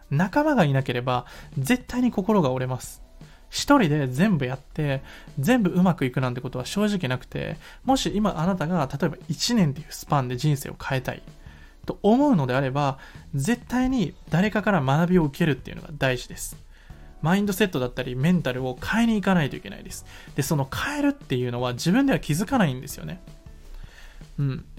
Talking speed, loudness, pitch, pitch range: 385 characters per minute, -24 LUFS, 155 Hz, 130-195 Hz